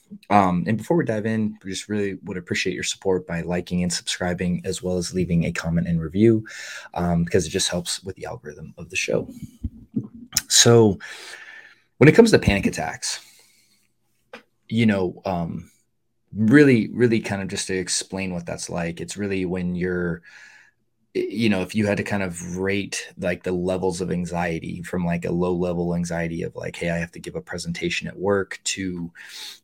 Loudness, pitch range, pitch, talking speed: -22 LUFS, 90-105 Hz, 95 Hz, 185 wpm